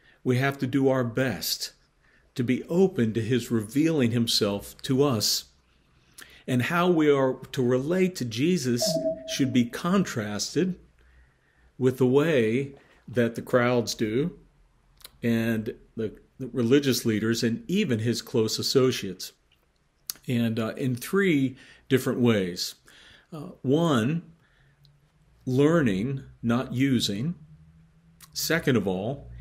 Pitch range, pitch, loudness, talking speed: 115-145 Hz, 130 Hz, -26 LUFS, 115 wpm